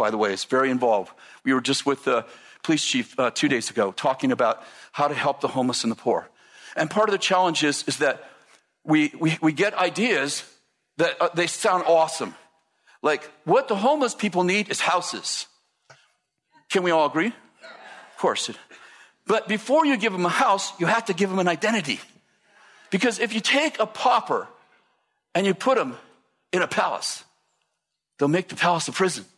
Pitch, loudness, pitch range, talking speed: 185 Hz, -23 LUFS, 160-220 Hz, 190 wpm